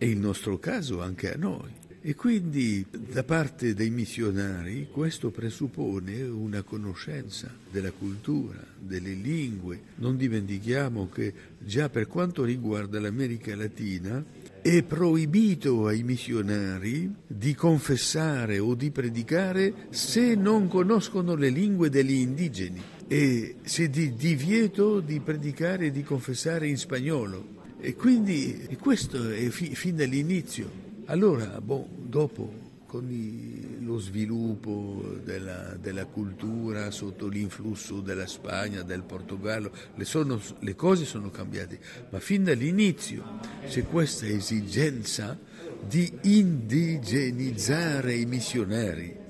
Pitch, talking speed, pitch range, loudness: 125 Hz, 120 wpm, 105-155 Hz, -28 LUFS